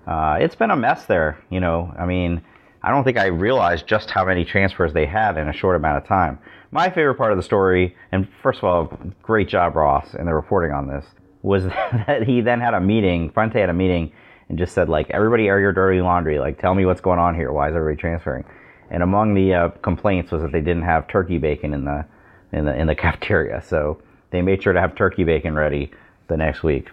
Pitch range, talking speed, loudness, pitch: 80-95 Hz, 240 wpm, -20 LUFS, 90 Hz